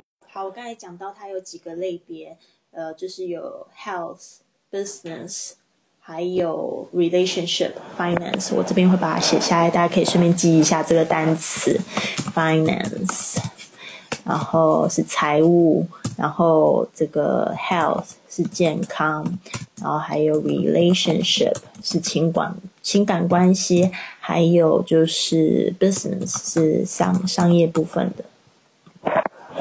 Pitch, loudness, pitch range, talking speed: 175 Hz, -20 LUFS, 165-185 Hz, 285 characters per minute